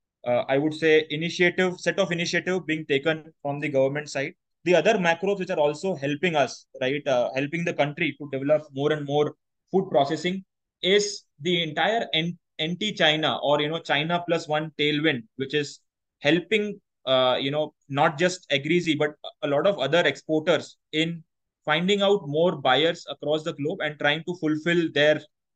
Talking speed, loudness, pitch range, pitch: 170 wpm, -24 LUFS, 145-170 Hz, 155 Hz